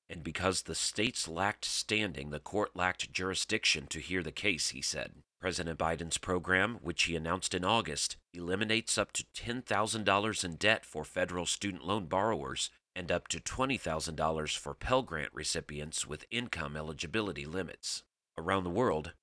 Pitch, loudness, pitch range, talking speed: 90 Hz, -33 LUFS, 80-105 Hz, 155 wpm